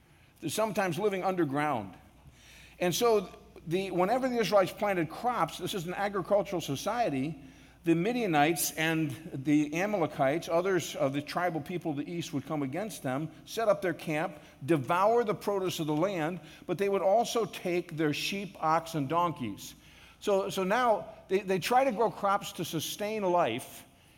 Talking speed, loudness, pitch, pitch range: 160 wpm, -30 LUFS, 175 Hz, 155-200 Hz